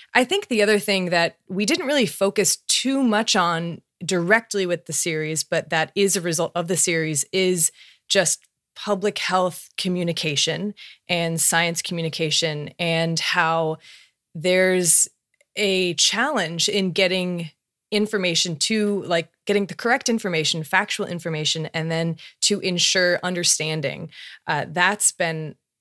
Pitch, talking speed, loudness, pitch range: 175 Hz, 135 wpm, -21 LUFS, 165-195 Hz